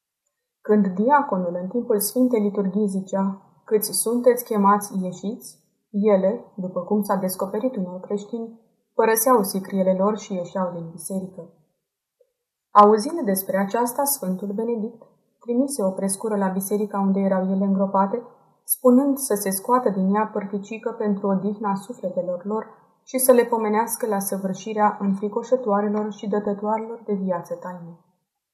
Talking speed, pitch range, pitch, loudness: 130 wpm, 195-230 Hz, 205 Hz, -22 LUFS